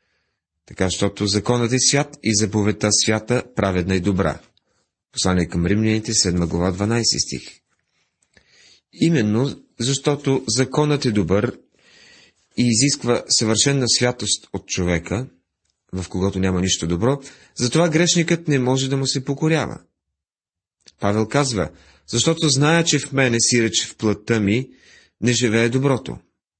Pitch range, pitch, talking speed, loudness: 95-135 Hz, 110 Hz, 130 wpm, -19 LUFS